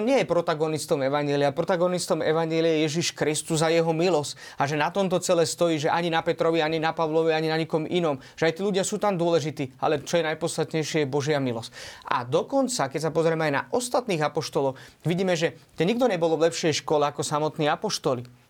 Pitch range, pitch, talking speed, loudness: 150-170 Hz, 160 Hz, 205 wpm, -25 LUFS